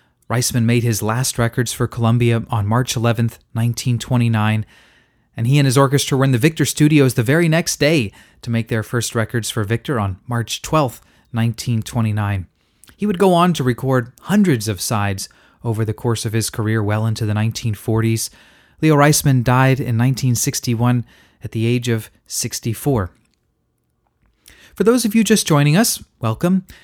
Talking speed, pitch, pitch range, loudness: 165 wpm, 120 Hz, 110-140 Hz, -18 LUFS